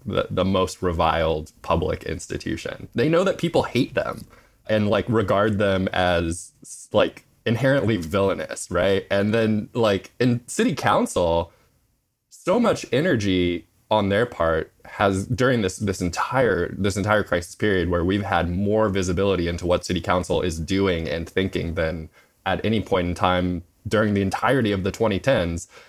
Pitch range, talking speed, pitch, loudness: 90-110 Hz, 155 wpm, 95 Hz, -22 LUFS